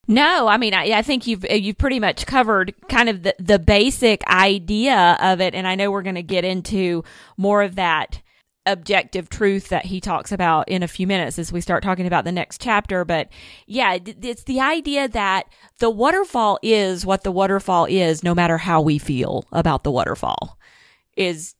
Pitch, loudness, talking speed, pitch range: 195 Hz, -19 LUFS, 195 wpm, 175-215 Hz